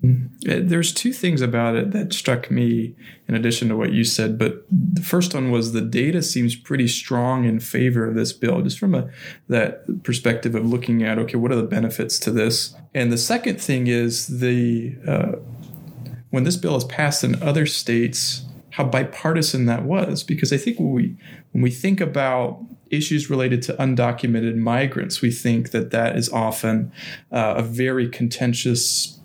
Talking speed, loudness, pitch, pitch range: 180 wpm, -21 LUFS, 125 Hz, 115-150 Hz